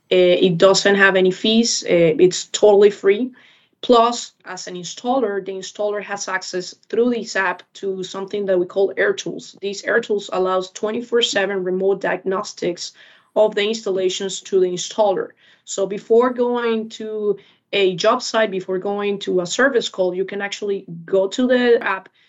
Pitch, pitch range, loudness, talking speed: 200 Hz, 190-220 Hz, -19 LUFS, 155 wpm